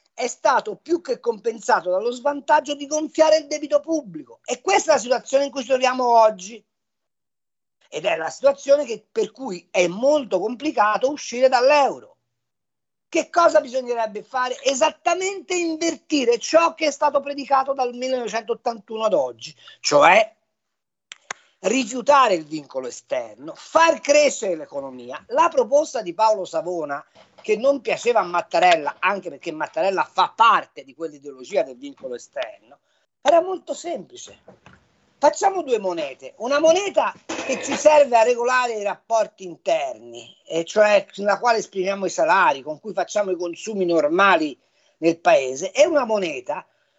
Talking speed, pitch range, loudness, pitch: 140 wpm, 210-310 Hz, -20 LUFS, 265 Hz